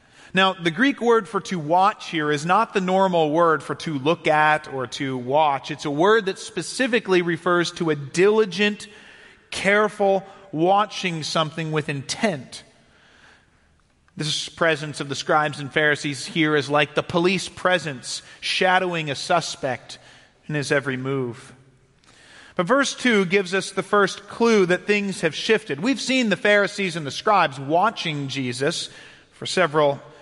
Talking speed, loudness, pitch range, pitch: 155 wpm, -21 LUFS, 150-200 Hz, 170 Hz